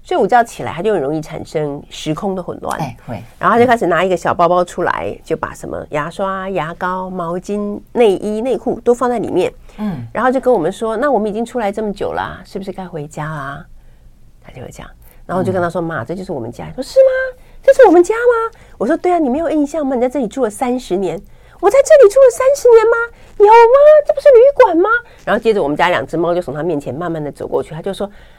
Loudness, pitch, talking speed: -14 LUFS, 205 Hz, 345 characters per minute